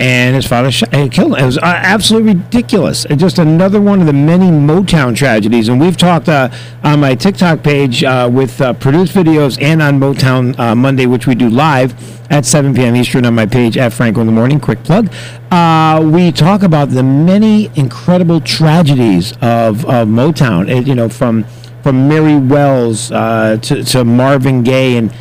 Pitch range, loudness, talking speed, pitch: 120-160 Hz, -9 LUFS, 190 wpm, 135 Hz